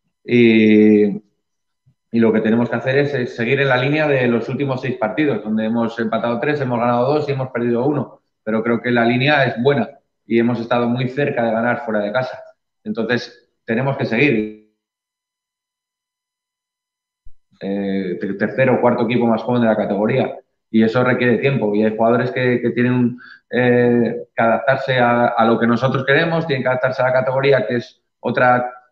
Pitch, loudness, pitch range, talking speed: 120 Hz, -17 LUFS, 115-135 Hz, 185 wpm